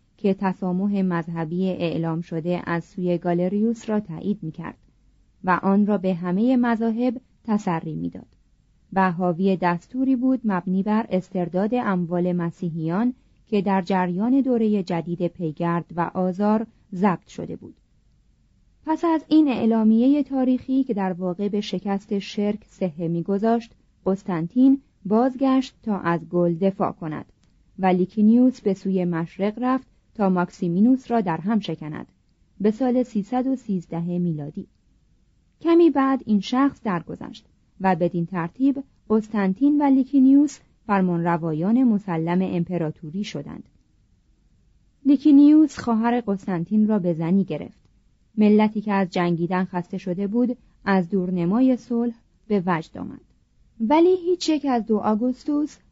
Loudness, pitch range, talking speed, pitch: -22 LUFS, 175-240 Hz, 125 wpm, 200 Hz